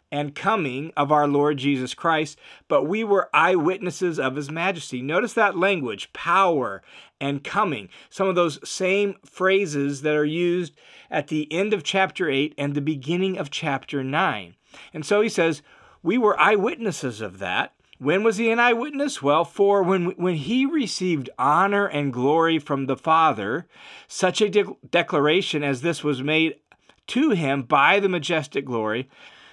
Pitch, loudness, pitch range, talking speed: 165 Hz, -22 LUFS, 145-195 Hz, 165 wpm